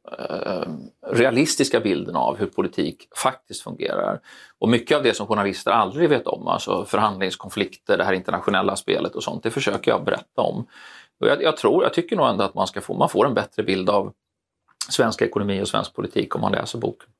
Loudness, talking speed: -22 LUFS, 190 wpm